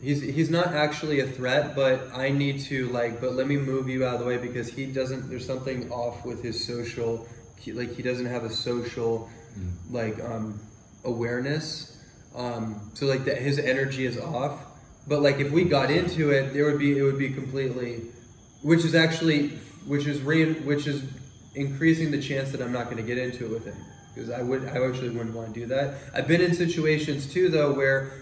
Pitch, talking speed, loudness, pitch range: 130 Hz, 210 wpm, -27 LUFS, 120-145 Hz